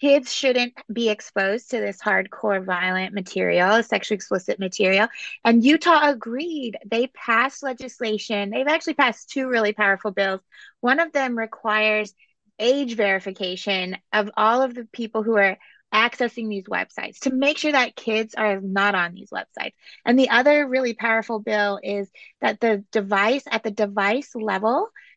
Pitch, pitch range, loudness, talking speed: 225 Hz, 205-260 Hz, -22 LUFS, 155 wpm